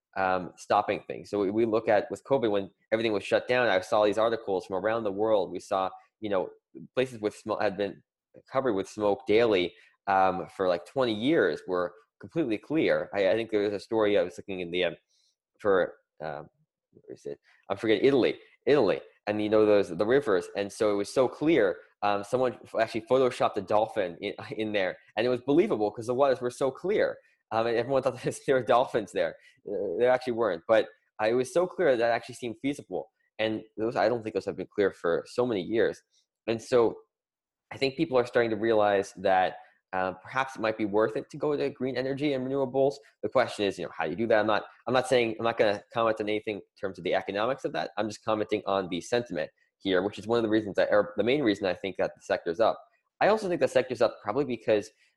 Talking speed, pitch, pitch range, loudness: 235 wpm, 115 Hz, 105-140 Hz, -28 LUFS